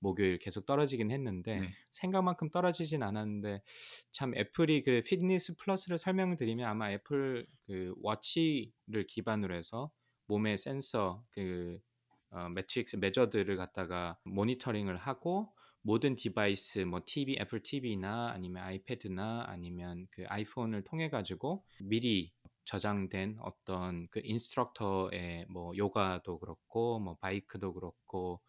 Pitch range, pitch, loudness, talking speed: 95-125 Hz, 105 Hz, -36 LUFS, 305 characters per minute